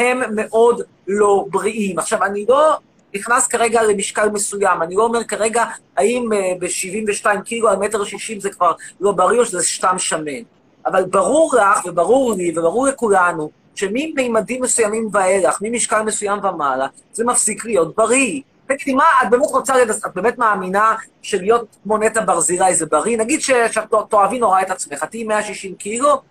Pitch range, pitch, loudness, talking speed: 195-235 Hz, 215 Hz, -17 LUFS, 155 wpm